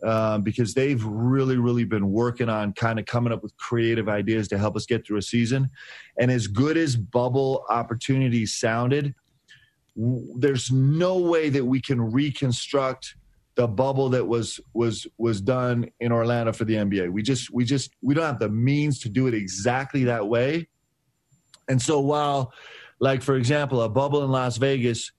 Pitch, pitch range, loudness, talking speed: 125 Hz, 115-135 Hz, -24 LUFS, 185 wpm